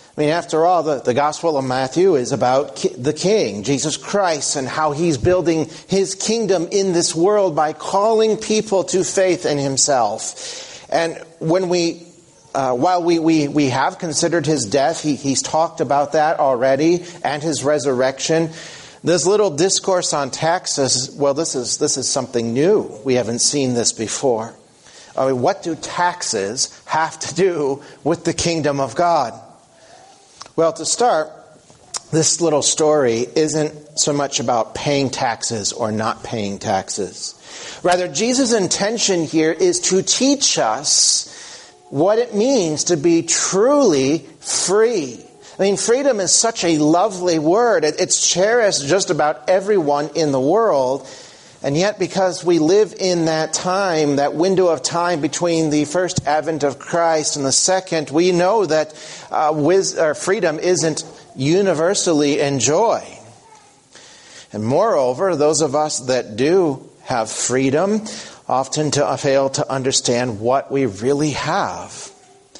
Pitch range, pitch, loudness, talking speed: 145-180 Hz, 160 Hz, -17 LUFS, 145 wpm